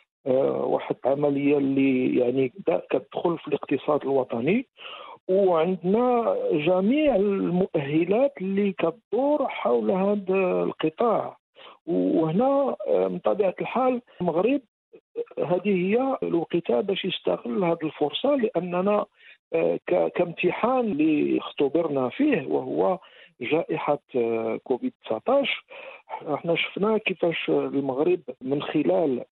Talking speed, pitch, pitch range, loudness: 85 wpm, 185 Hz, 155-255 Hz, -25 LUFS